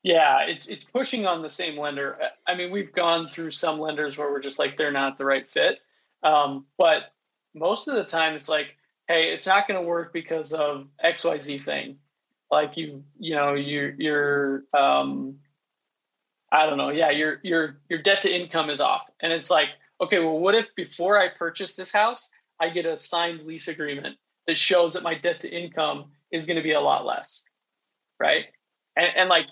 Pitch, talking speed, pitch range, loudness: 160 Hz, 200 wpm, 145-175 Hz, -24 LUFS